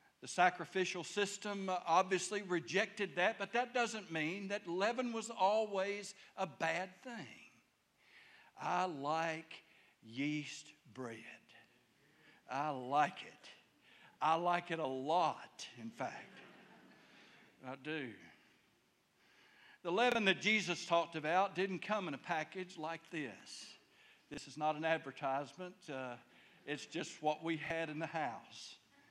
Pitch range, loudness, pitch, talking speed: 155-190 Hz, -38 LUFS, 170 Hz, 125 wpm